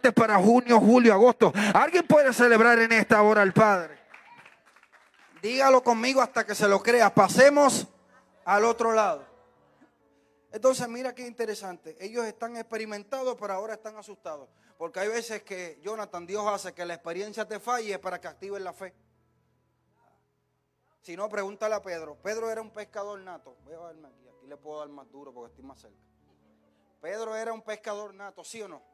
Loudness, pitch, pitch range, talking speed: -23 LUFS, 210 Hz, 185-230 Hz, 170 wpm